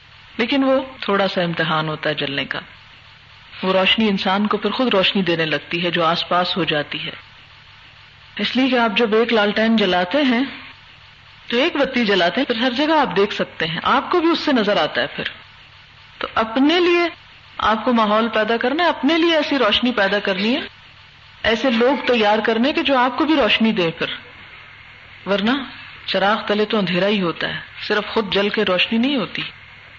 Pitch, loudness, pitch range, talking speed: 210 Hz, -18 LUFS, 180-255 Hz, 195 wpm